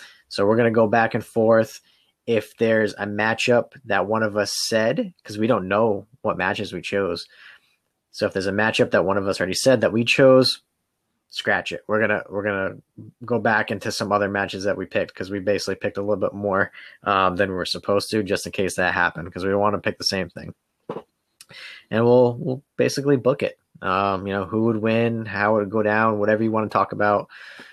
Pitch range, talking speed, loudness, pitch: 100-115 Hz, 235 wpm, -21 LUFS, 110 Hz